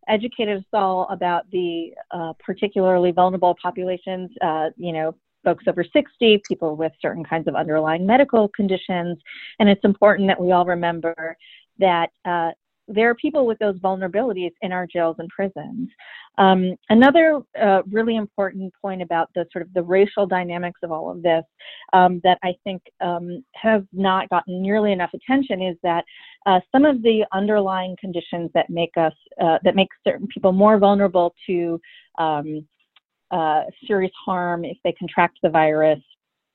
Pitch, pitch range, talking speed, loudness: 185 Hz, 170-200 Hz, 165 wpm, -20 LUFS